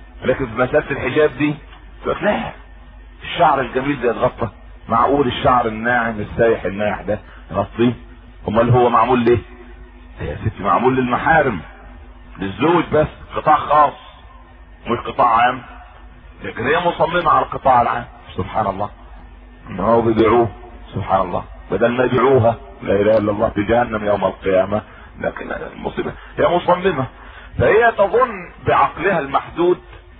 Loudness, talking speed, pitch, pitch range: -17 LUFS, 125 wpm, 115 Hz, 100-130 Hz